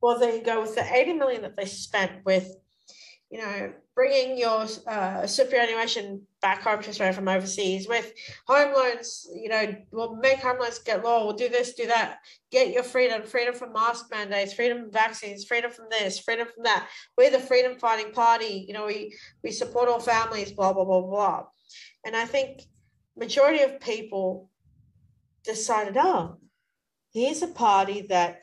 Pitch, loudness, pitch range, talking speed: 225 Hz, -25 LUFS, 200-245 Hz, 175 wpm